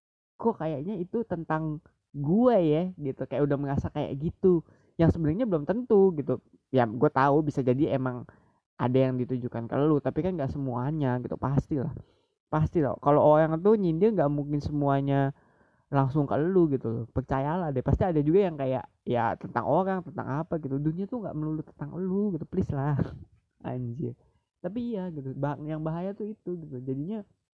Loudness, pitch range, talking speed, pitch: -28 LUFS, 135-170 Hz, 175 wpm, 150 Hz